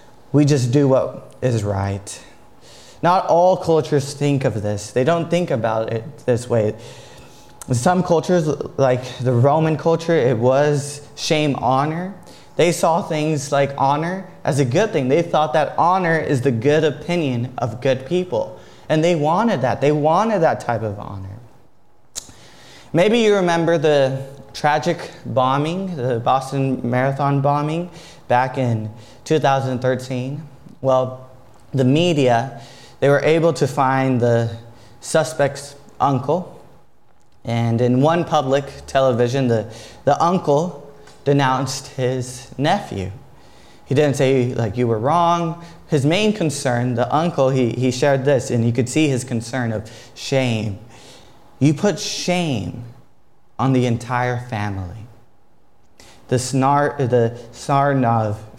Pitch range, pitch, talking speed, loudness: 120-155 Hz, 135 Hz, 130 wpm, -19 LUFS